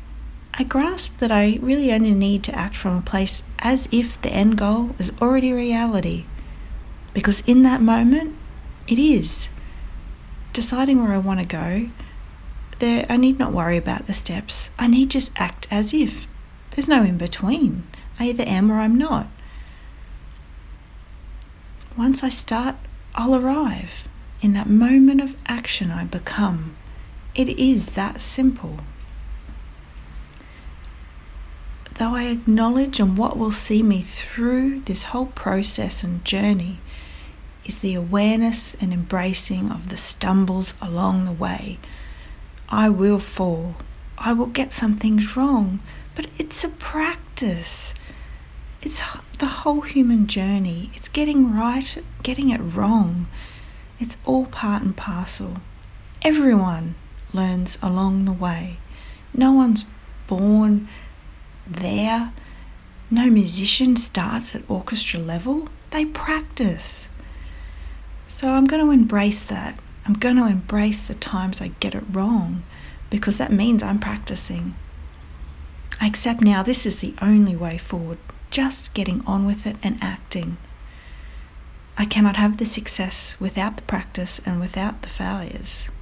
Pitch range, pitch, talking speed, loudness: 170-240 Hz, 205 Hz, 135 wpm, -20 LUFS